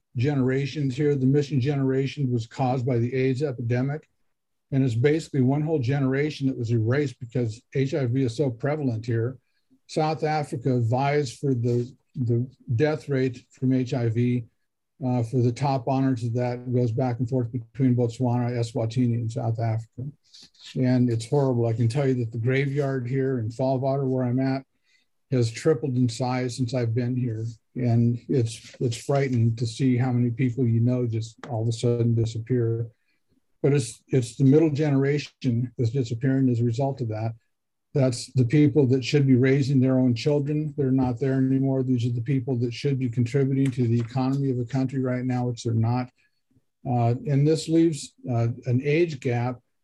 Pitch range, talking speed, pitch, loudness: 120-135 Hz, 180 wpm, 130 Hz, -25 LUFS